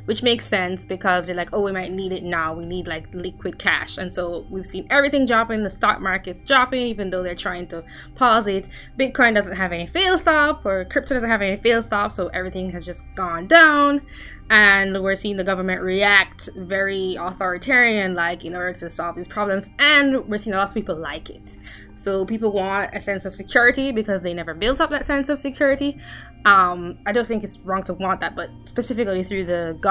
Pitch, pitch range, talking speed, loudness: 195 Hz, 180-240 Hz, 215 wpm, -20 LUFS